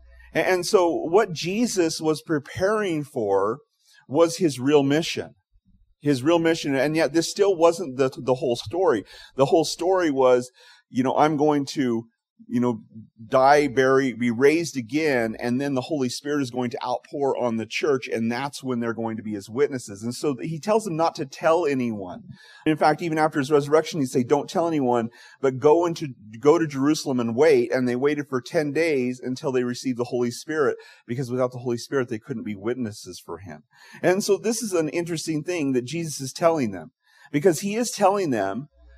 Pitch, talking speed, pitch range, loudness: 145 Hz, 195 wpm, 125-165 Hz, -23 LUFS